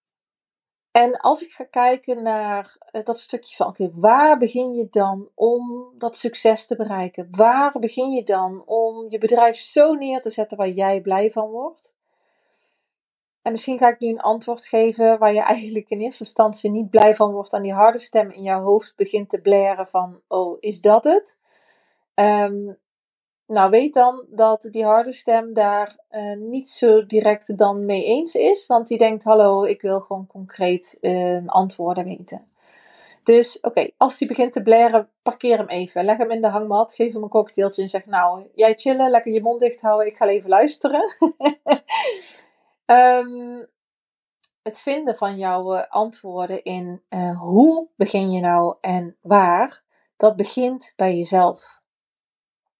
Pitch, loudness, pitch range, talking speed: 220 Hz, -19 LUFS, 200-240 Hz, 170 wpm